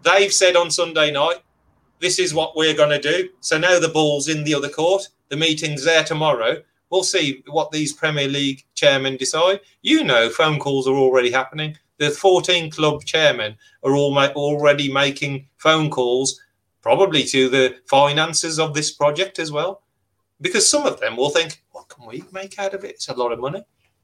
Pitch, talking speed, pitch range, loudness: 155 Hz, 190 wpm, 140-180 Hz, -18 LUFS